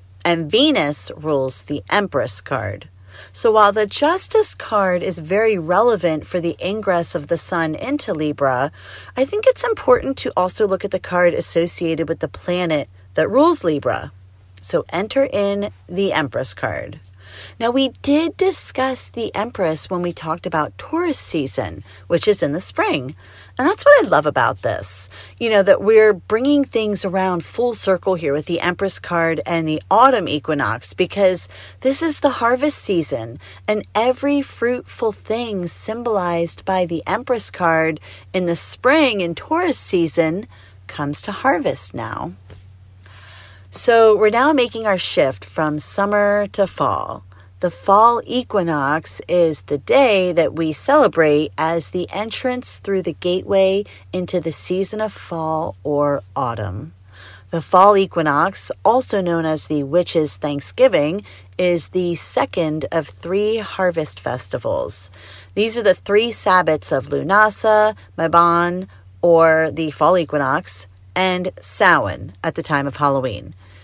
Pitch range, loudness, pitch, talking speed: 145-210 Hz, -18 LUFS, 175 Hz, 145 wpm